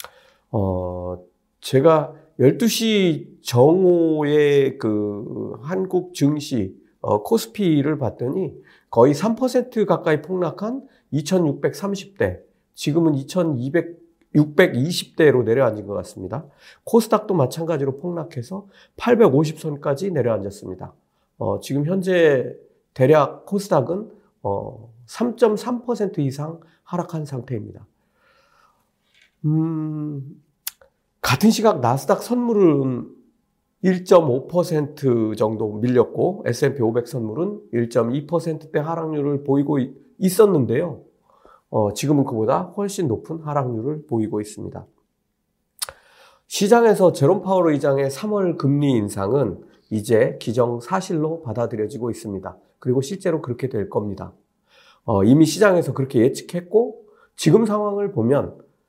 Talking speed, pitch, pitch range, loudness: 215 characters per minute, 155 Hz, 125-190 Hz, -20 LUFS